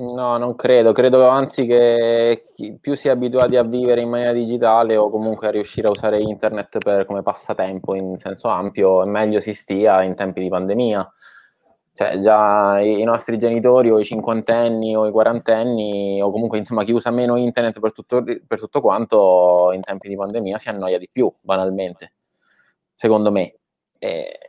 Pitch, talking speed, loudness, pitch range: 110 Hz, 175 wpm, -18 LUFS, 100-120 Hz